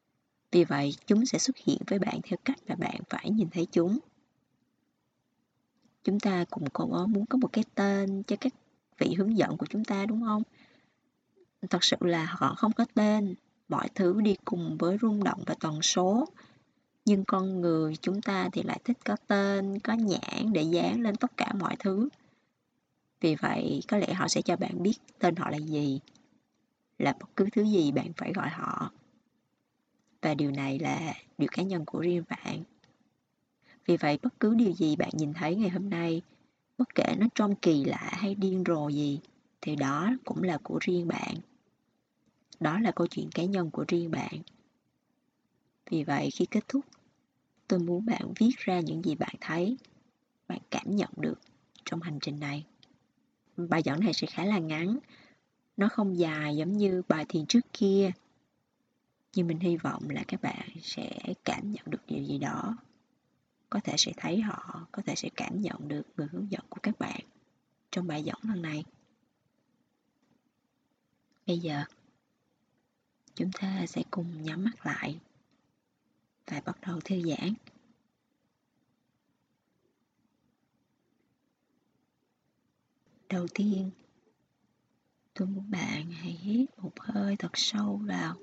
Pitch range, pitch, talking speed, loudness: 175-230 Hz, 195 Hz, 165 wpm, -30 LUFS